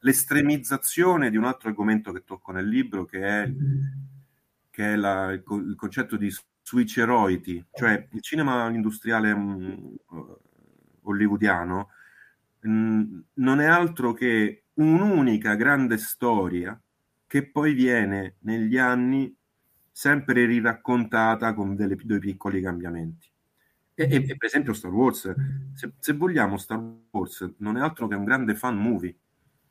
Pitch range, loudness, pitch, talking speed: 100-135 Hz, -24 LUFS, 115 Hz, 130 wpm